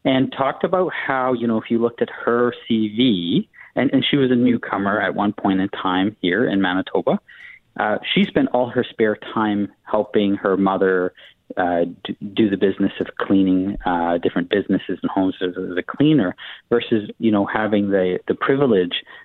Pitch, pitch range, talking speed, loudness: 110 Hz, 95-125 Hz, 180 wpm, -20 LUFS